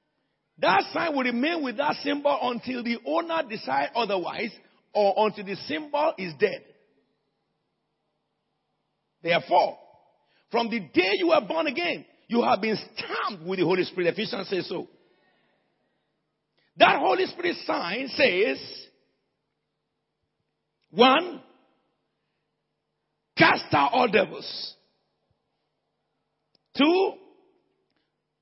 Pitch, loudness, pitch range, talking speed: 275 Hz, -25 LUFS, 215-330 Hz, 100 wpm